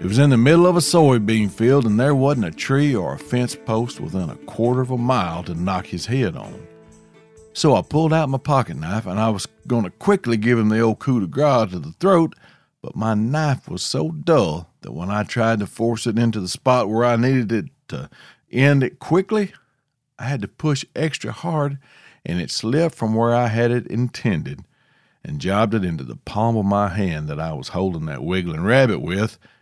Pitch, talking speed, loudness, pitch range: 120 Hz, 220 wpm, -20 LUFS, 110-145 Hz